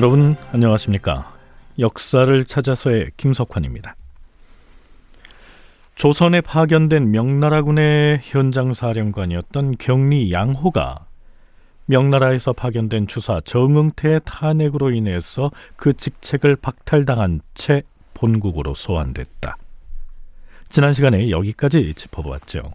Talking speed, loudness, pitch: 260 characters per minute, -18 LUFS, 120 Hz